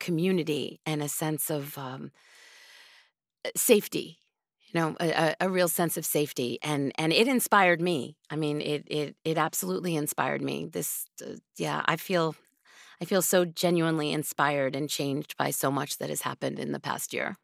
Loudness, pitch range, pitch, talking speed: -28 LUFS, 150-175 Hz, 155 Hz, 170 wpm